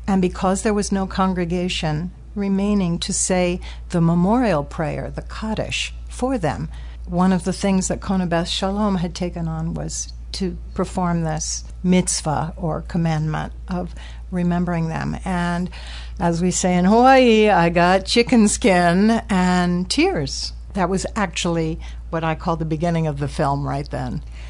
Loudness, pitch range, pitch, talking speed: -20 LUFS, 160-190 Hz, 180 Hz, 150 wpm